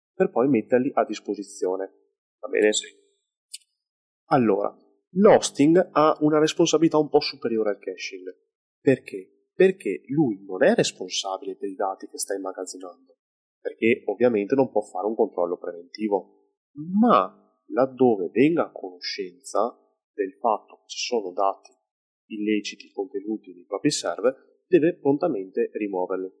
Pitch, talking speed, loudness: 155 Hz, 125 wpm, -24 LUFS